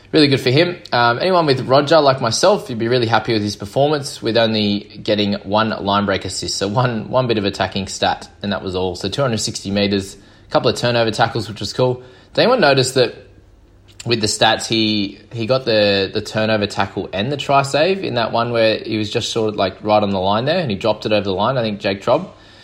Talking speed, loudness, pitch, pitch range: 240 wpm, -17 LUFS, 110 Hz, 100-125 Hz